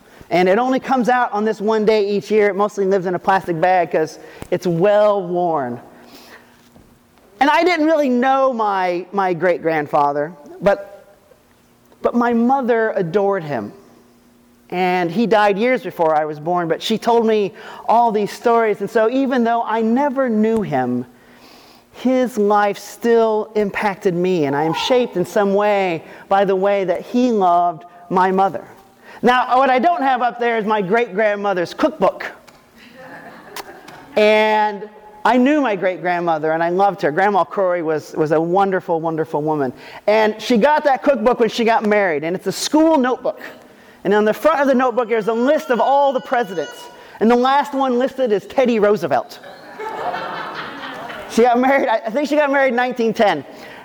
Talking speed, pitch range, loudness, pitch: 175 wpm, 185-245 Hz, -17 LUFS, 210 Hz